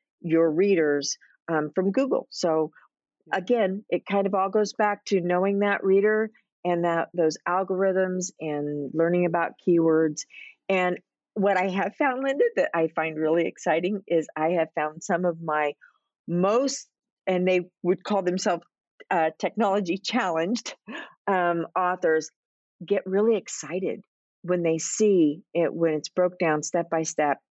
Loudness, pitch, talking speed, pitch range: -25 LUFS, 180 Hz, 150 wpm, 165-195 Hz